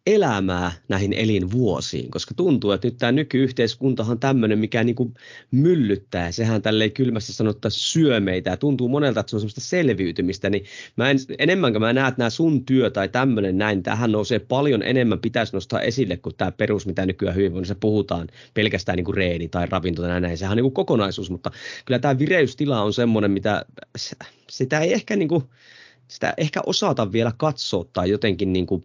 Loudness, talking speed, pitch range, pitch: -22 LUFS, 180 wpm, 100-130 Hz, 110 Hz